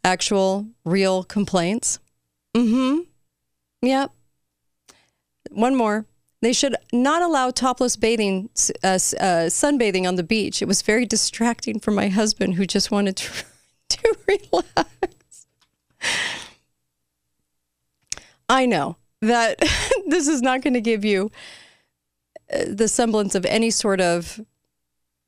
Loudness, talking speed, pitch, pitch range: -21 LUFS, 120 wpm, 210 Hz, 180-245 Hz